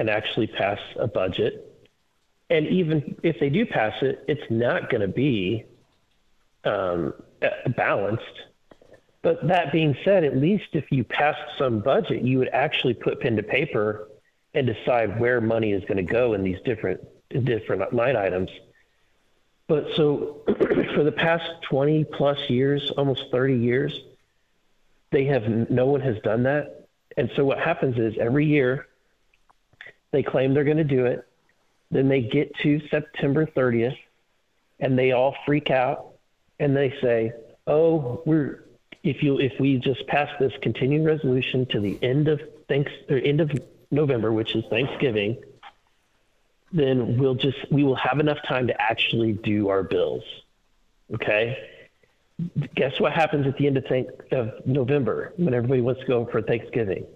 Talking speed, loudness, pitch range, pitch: 155 wpm, -24 LUFS, 125-150 Hz, 140 Hz